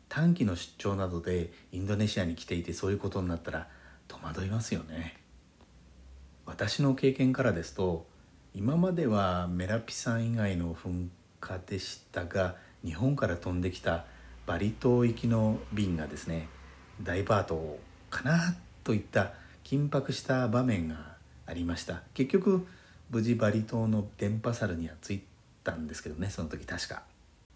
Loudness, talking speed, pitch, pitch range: -32 LUFS, 300 characters per minute, 95 Hz, 85-115 Hz